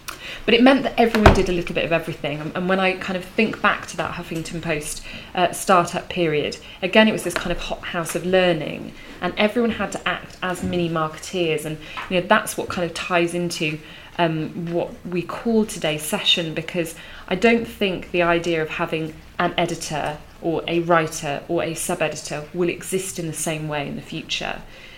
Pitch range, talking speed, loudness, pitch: 160-185 Hz, 200 wpm, -22 LUFS, 175 Hz